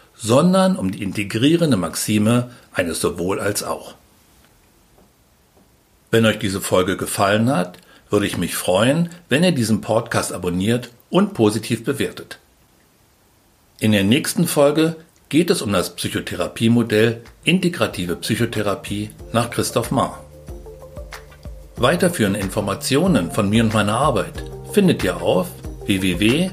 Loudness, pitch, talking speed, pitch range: -19 LUFS, 110 Hz, 120 wpm, 95-120 Hz